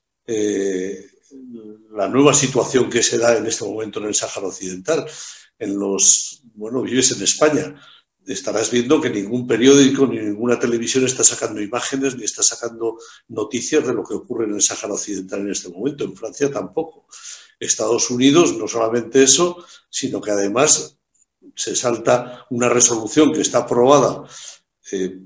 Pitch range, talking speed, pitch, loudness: 105-135 Hz, 155 wpm, 120 Hz, -17 LUFS